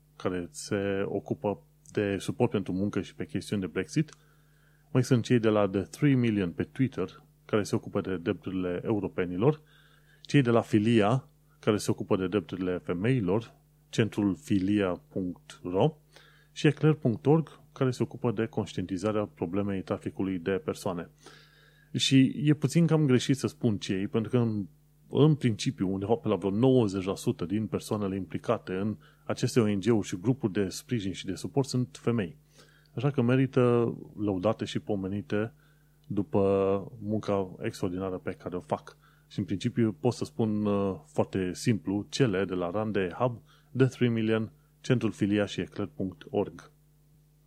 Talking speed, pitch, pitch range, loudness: 145 wpm, 115 Hz, 100-140 Hz, -29 LUFS